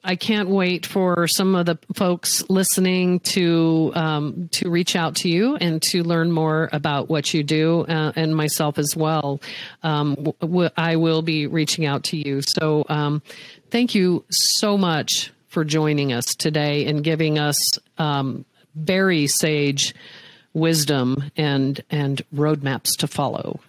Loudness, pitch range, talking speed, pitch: -20 LUFS, 150-175 Hz, 150 wpm, 160 Hz